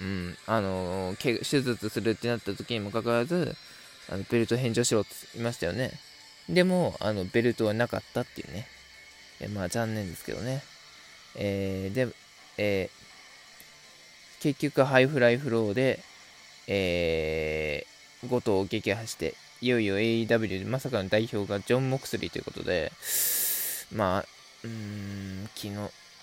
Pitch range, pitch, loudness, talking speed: 100-125 Hz, 115 Hz, -29 LUFS, 280 characters per minute